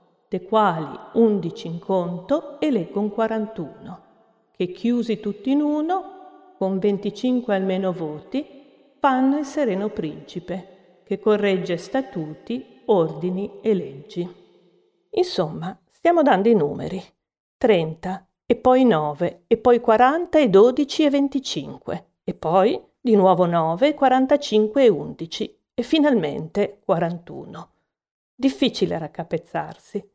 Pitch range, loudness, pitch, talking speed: 180-265 Hz, -21 LUFS, 210 Hz, 110 wpm